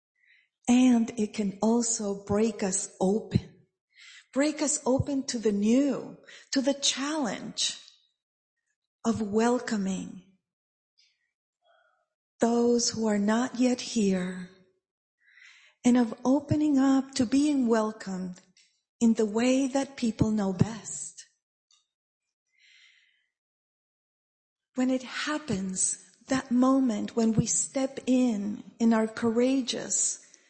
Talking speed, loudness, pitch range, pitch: 100 wpm, -27 LUFS, 210-265 Hz, 235 Hz